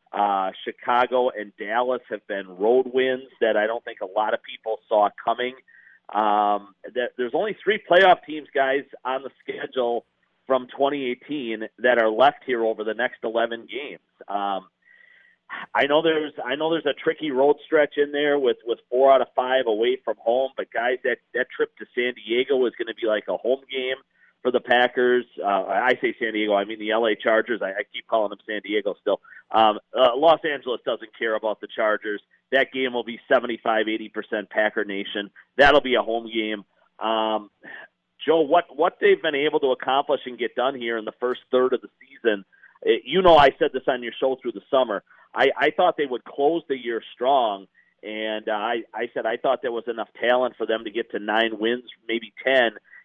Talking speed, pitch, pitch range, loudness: 205 wpm, 125 Hz, 110-140 Hz, -23 LUFS